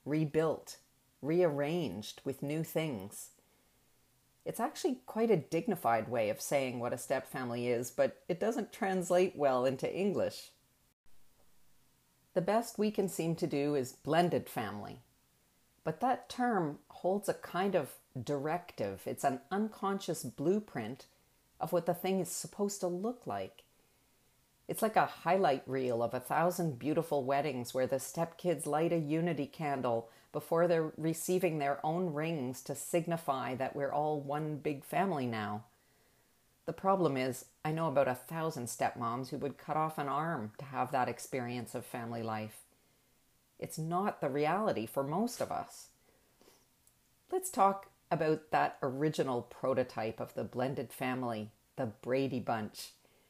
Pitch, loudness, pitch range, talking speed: 150 Hz, -35 LUFS, 130-175 Hz, 145 wpm